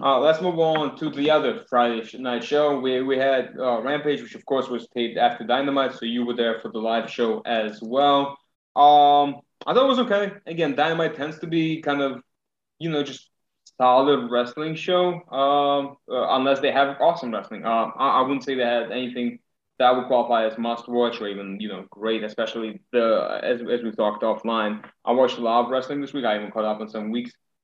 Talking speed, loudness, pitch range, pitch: 215 wpm, -23 LUFS, 115-145 Hz, 130 Hz